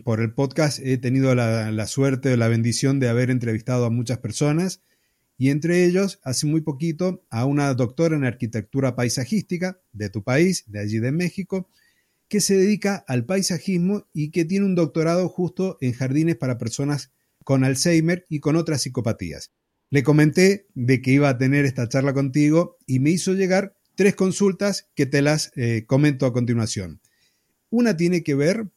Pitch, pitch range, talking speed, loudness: 145 Hz, 125-180 Hz, 175 wpm, -22 LUFS